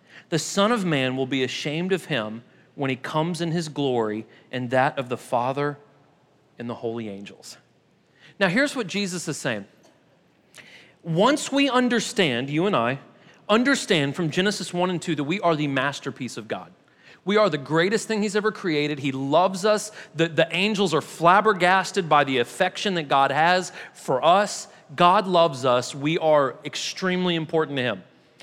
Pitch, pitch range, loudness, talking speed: 165 Hz, 140-195 Hz, -23 LUFS, 175 wpm